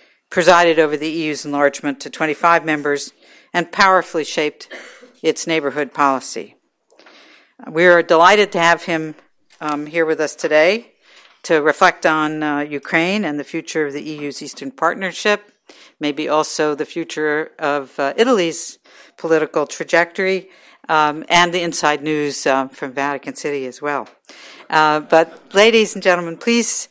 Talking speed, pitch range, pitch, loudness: 145 wpm, 150-175 Hz, 160 Hz, -17 LUFS